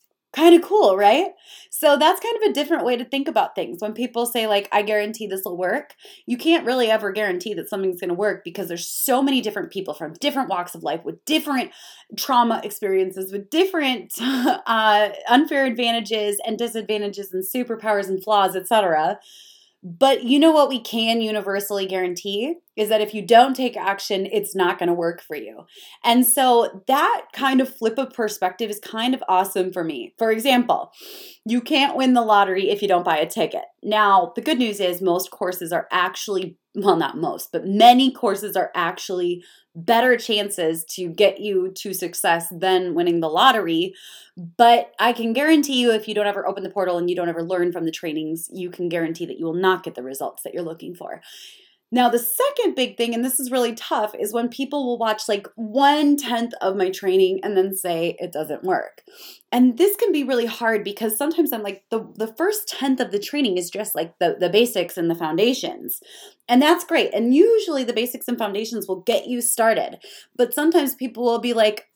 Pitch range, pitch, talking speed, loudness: 190-260 Hz, 220 Hz, 205 wpm, -20 LUFS